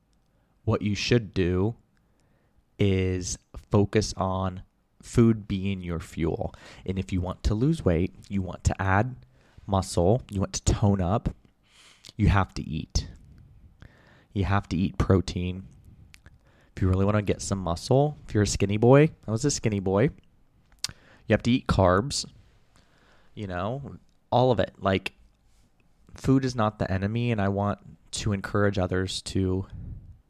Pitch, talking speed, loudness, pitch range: 100 Hz, 155 wpm, -26 LUFS, 95-110 Hz